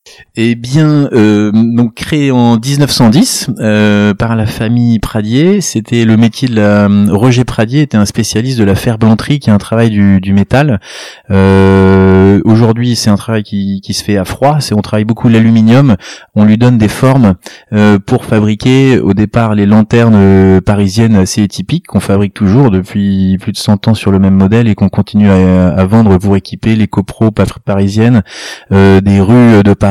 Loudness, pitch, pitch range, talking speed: -8 LUFS, 110 Hz, 100-120 Hz, 185 wpm